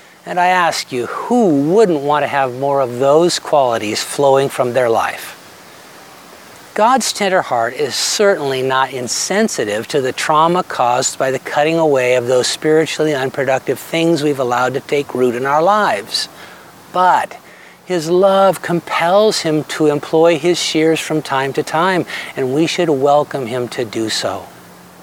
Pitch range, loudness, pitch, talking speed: 130-170 Hz, -15 LUFS, 150 Hz, 160 wpm